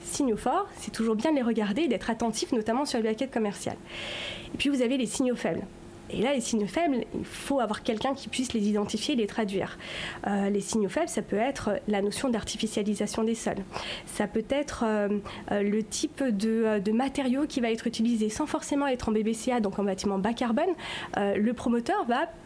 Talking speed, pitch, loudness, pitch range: 210 wpm, 225 Hz, -29 LUFS, 215-265 Hz